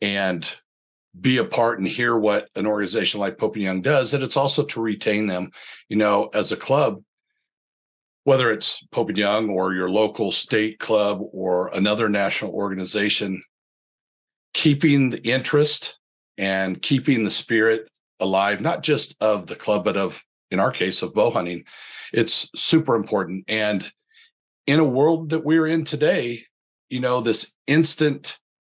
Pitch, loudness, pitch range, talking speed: 110 Hz, -21 LUFS, 100-140 Hz, 155 wpm